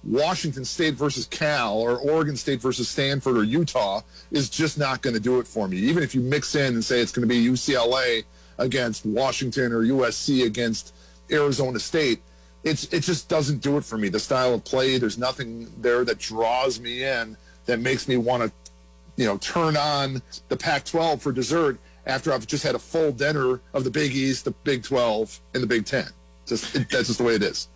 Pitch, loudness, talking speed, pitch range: 130 Hz, -24 LUFS, 210 wpm, 115-145 Hz